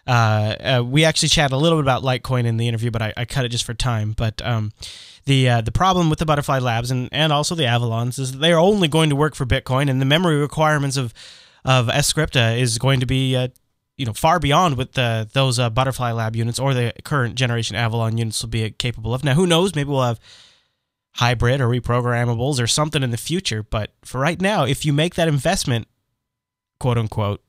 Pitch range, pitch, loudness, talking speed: 115-145 Hz, 125 Hz, -19 LUFS, 225 wpm